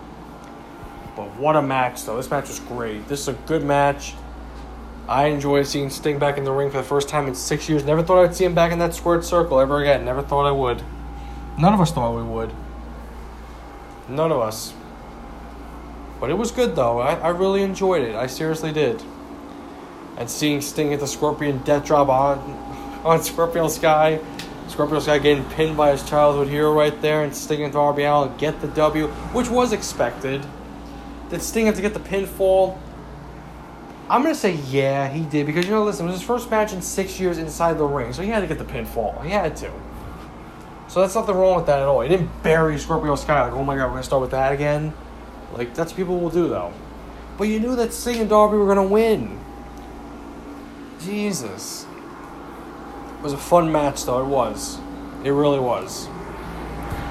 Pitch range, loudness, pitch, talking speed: 135-175 Hz, -21 LUFS, 150 Hz, 205 wpm